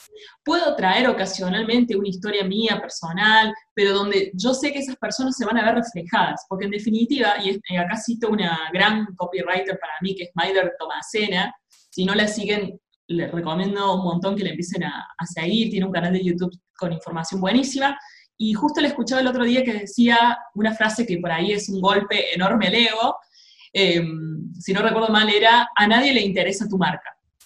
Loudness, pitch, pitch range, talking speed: -21 LUFS, 200 Hz, 185-225 Hz, 190 wpm